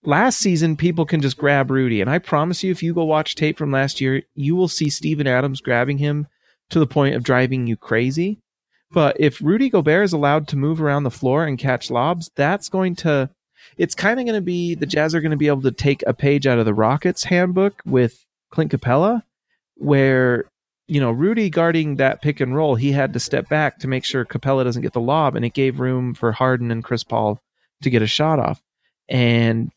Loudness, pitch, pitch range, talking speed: -19 LUFS, 145 Hz, 130-165 Hz, 225 wpm